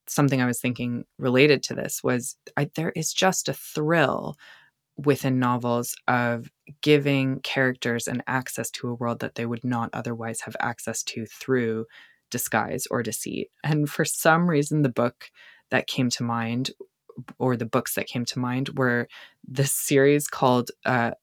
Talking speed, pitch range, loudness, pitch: 165 wpm, 120-145 Hz, -25 LUFS, 130 Hz